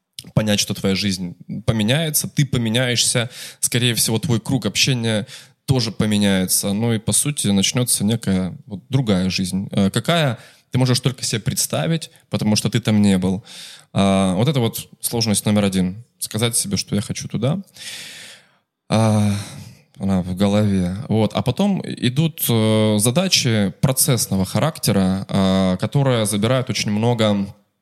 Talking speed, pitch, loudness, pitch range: 140 wpm, 115 Hz, -19 LUFS, 100-130 Hz